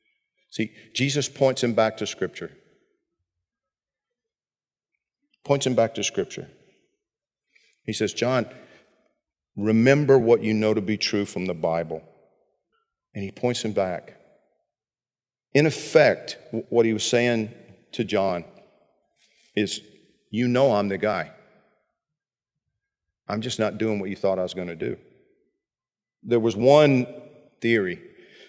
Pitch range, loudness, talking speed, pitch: 105-135 Hz, -23 LUFS, 125 wpm, 115 Hz